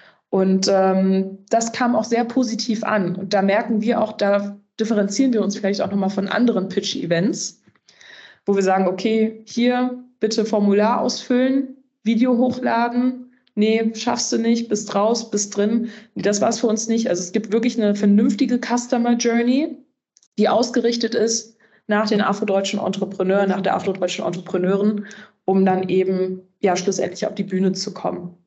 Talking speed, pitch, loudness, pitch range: 160 wpm, 215 Hz, -20 LUFS, 195-235 Hz